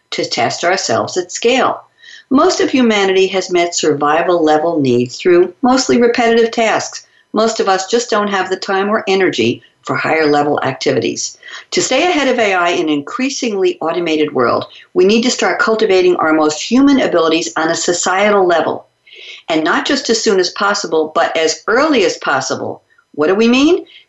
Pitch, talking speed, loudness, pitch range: 215 Hz, 175 wpm, -13 LUFS, 170-285 Hz